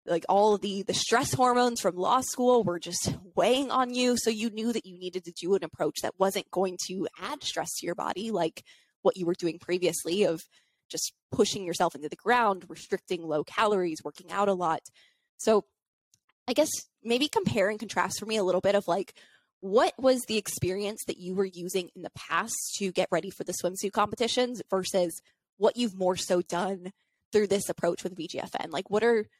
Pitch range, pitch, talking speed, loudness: 175-220 Hz, 195 Hz, 210 wpm, -28 LUFS